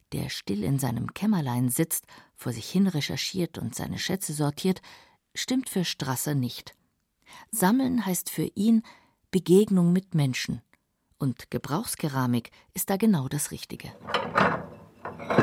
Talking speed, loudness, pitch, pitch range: 125 wpm, -27 LUFS, 175 Hz, 135-195 Hz